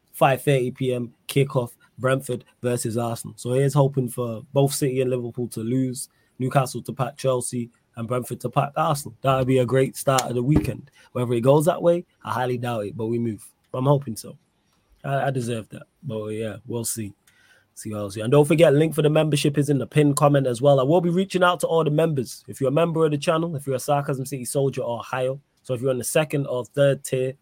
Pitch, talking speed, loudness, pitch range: 130 Hz, 235 wpm, -23 LUFS, 120-145 Hz